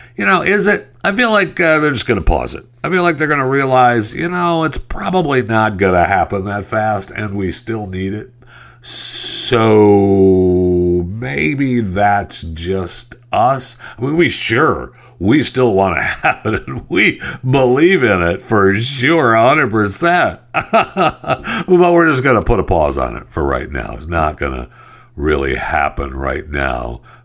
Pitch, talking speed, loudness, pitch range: 110 Hz, 175 wpm, -14 LUFS, 90-140 Hz